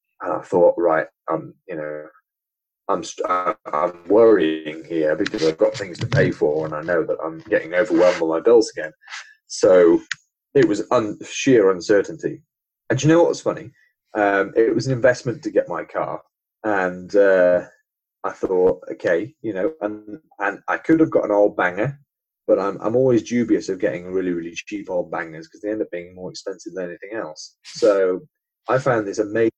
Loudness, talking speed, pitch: -20 LUFS, 190 wpm, 115 Hz